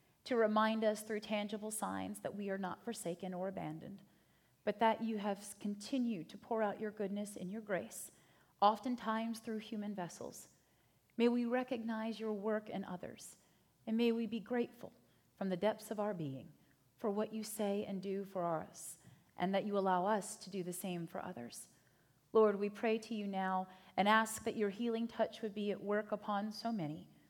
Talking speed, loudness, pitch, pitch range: 190 wpm, -39 LUFS, 210 Hz, 195-220 Hz